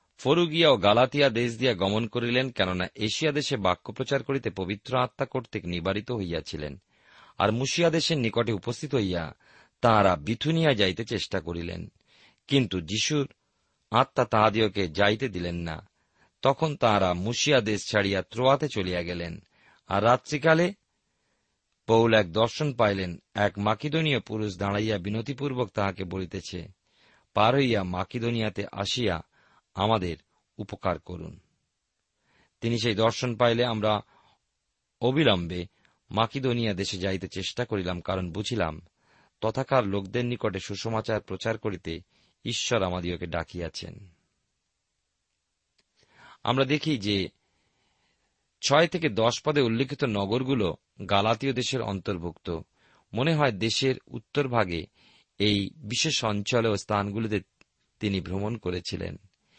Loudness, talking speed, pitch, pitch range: -27 LUFS, 110 wpm, 110 Hz, 95-125 Hz